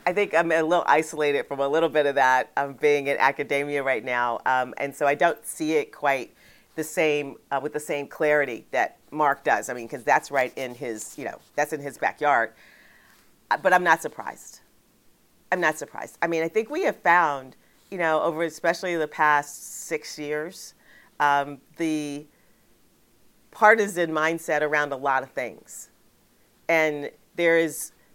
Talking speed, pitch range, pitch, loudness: 175 wpm, 140-165 Hz, 150 Hz, -24 LUFS